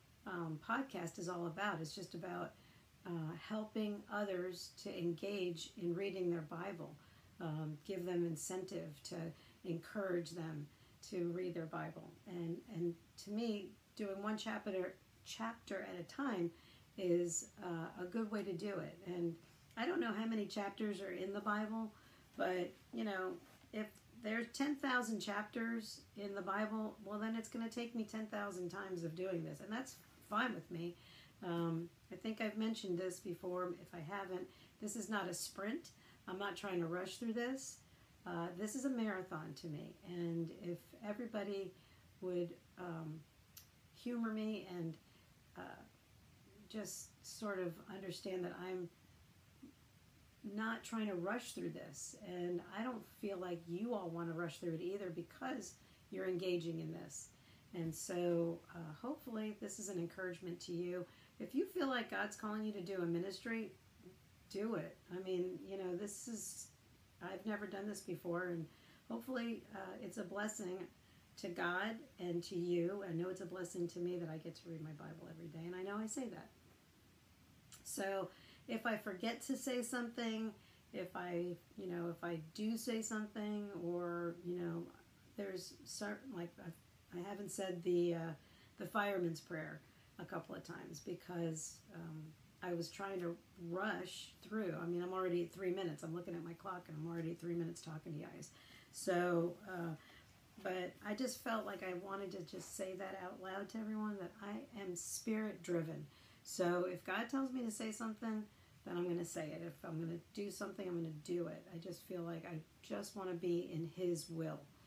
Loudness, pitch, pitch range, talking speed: -44 LUFS, 180 Hz, 170-205 Hz, 180 wpm